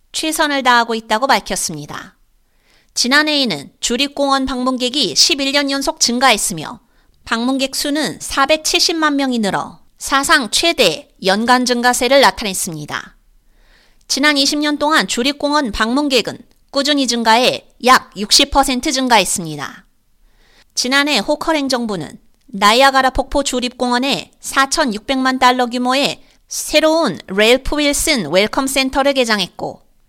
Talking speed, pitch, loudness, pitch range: 260 characters per minute, 265 Hz, -14 LUFS, 235-290 Hz